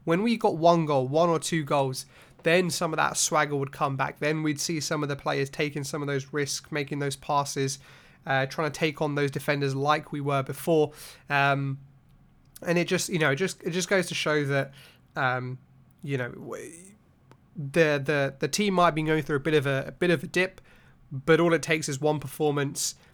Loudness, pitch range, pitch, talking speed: -26 LUFS, 140-165 Hz, 150 Hz, 220 wpm